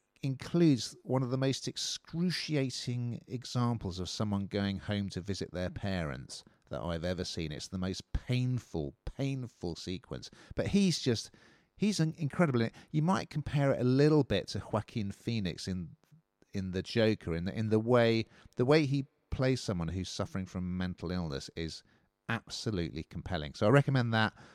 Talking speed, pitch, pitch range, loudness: 165 wpm, 110 Hz, 90-130 Hz, -33 LUFS